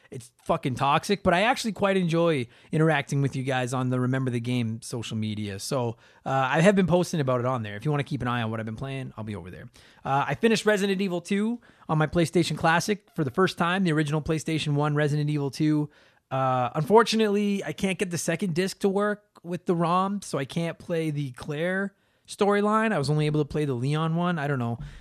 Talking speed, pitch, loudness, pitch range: 235 wpm, 155 Hz, -26 LUFS, 130-185 Hz